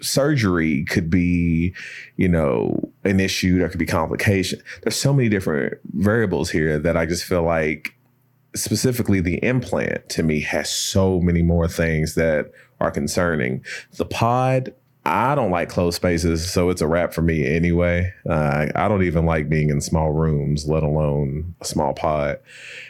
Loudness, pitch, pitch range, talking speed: -20 LUFS, 85 Hz, 80-95 Hz, 165 wpm